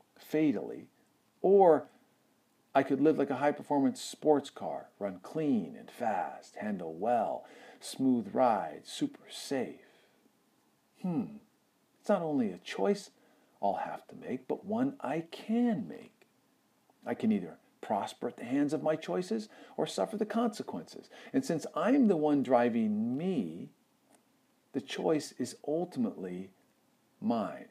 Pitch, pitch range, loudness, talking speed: 205 Hz, 150-235 Hz, -32 LUFS, 135 wpm